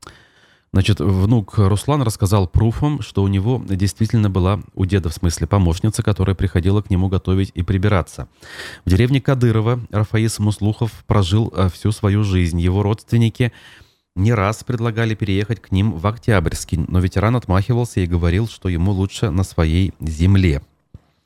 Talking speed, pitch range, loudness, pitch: 145 wpm, 95-110 Hz, -18 LUFS, 100 Hz